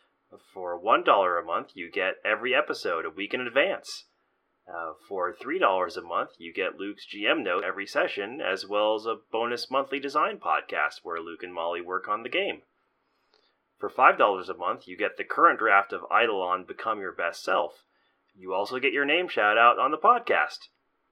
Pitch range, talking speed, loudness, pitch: 85-120 Hz, 185 wpm, -26 LUFS, 100 Hz